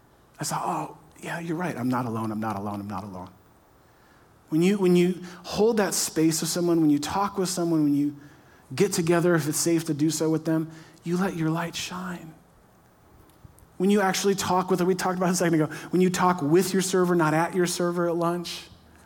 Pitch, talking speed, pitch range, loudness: 170 Hz, 220 wpm, 155-180 Hz, -25 LUFS